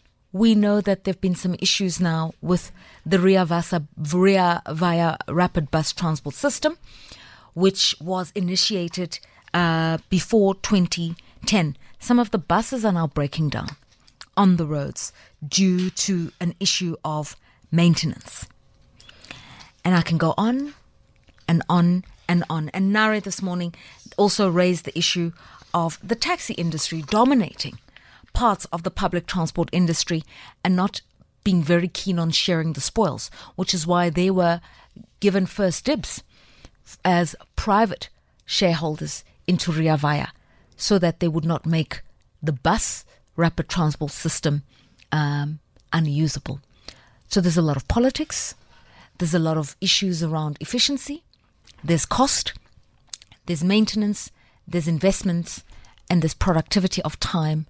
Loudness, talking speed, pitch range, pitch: -22 LUFS, 135 wpm, 160-190 Hz, 175 Hz